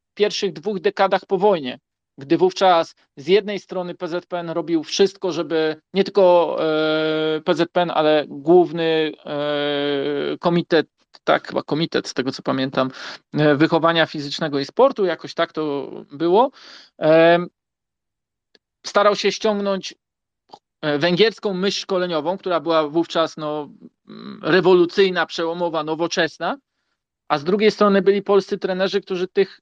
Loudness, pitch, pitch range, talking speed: -20 LUFS, 170 Hz, 155-195 Hz, 115 wpm